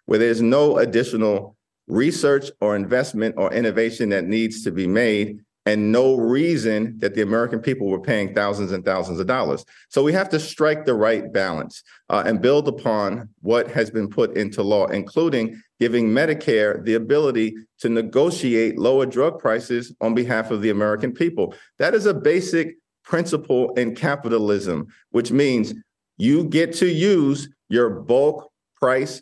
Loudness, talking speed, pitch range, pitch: -21 LUFS, 160 wpm, 110-140 Hz, 115 Hz